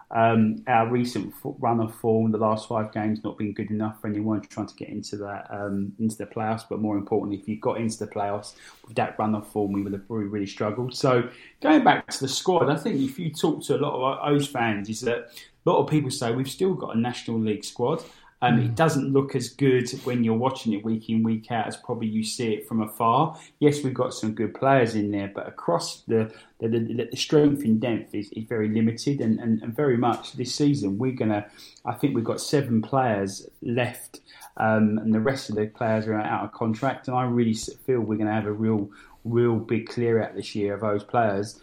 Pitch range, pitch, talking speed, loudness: 105-125 Hz, 110 Hz, 235 wpm, -25 LUFS